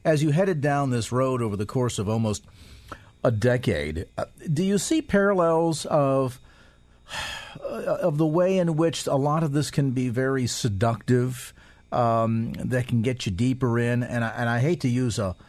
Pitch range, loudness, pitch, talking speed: 115-150 Hz, -24 LUFS, 125 Hz, 180 wpm